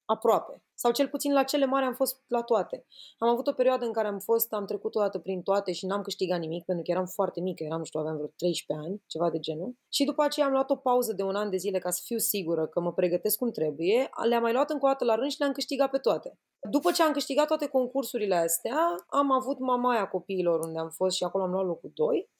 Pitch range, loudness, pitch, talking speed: 185-270 Hz, -28 LUFS, 220 Hz, 260 wpm